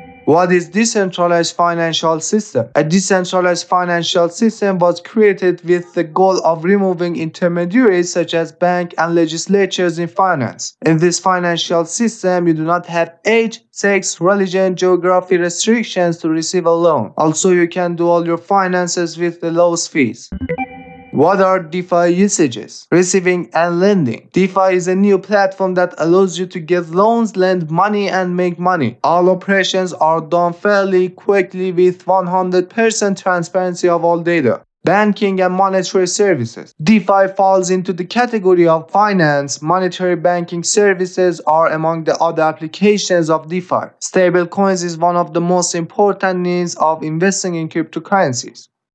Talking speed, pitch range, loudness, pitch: 150 wpm, 170-195 Hz, -14 LUFS, 180 Hz